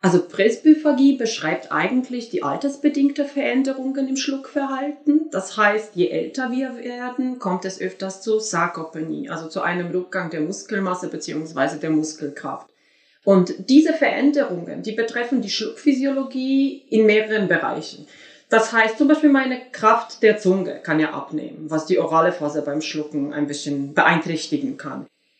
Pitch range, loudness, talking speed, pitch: 165-270 Hz, -21 LUFS, 140 wpm, 215 Hz